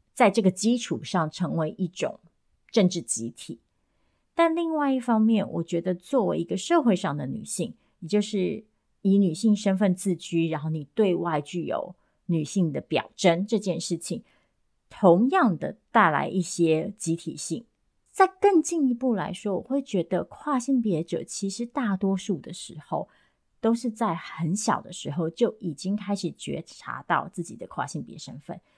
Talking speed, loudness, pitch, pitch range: 240 characters per minute, -26 LUFS, 195 Hz, 170-225 Hz